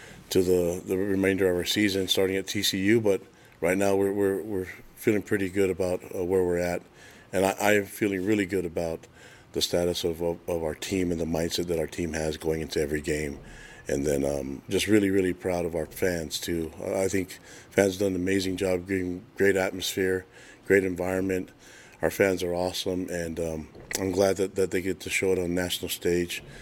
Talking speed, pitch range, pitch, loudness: 205 wpm, 85-95 Hz, 95 Hz, -27 LUFS